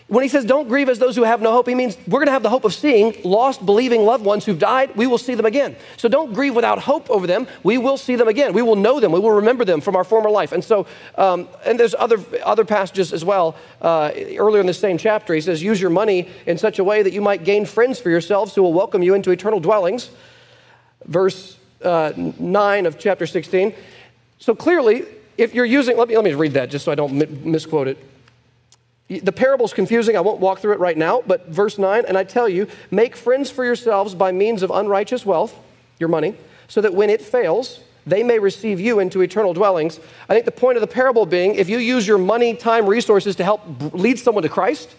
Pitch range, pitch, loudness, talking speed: 185-245 Hz, 210 Hz, -17 LUFS, 240 wpm